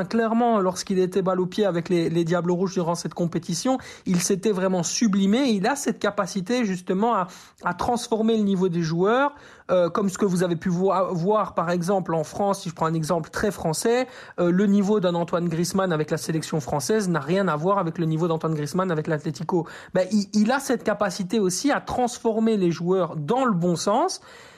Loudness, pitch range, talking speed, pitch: -23 LUFS, 175-215 Hz, 210 wpm, 190 Hz